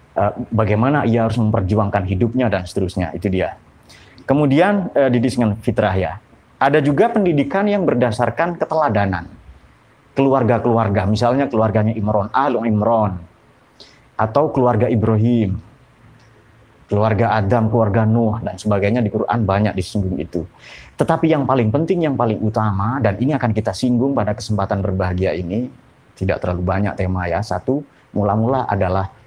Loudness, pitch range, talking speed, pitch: -18 LUFS, 100-125 Hz, 130 wpm, 110 Hz